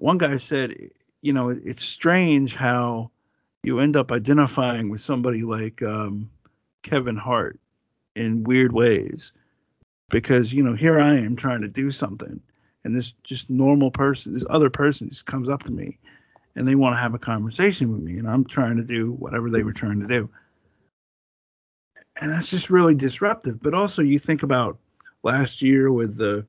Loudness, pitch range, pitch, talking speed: -22 LUFS, 115-140 Hz, 130 Hz, 175 wpm